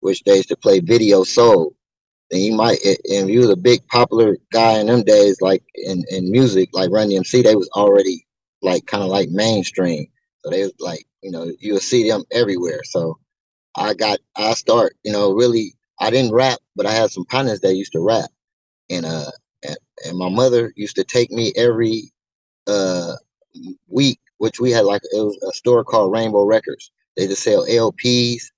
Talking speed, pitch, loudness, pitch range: 195 wpm, 115 Hz, -17 LUFS, 100-135 Hz